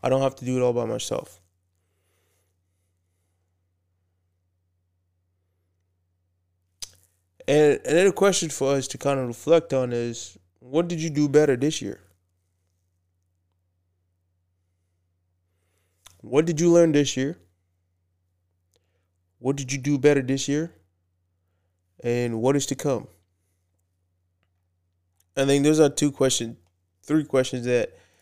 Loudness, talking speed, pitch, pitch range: -23 LUFS, 115 wpm, 90 Hz, 90-135 Hz